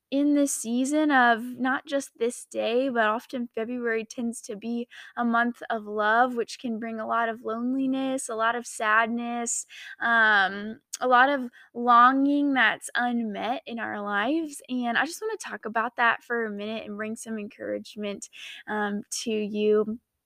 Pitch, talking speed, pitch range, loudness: 235 Hz, 170 wpm, 220-260 Hz, -26 LUFS